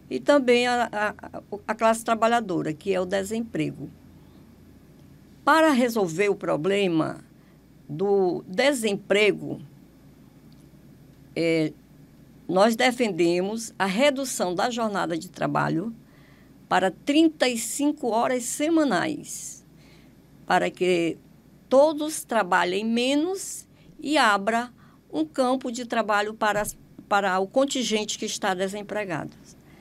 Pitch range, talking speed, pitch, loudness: 195-255 Hz, 95 wpm, 220 Hz, -24 LUFS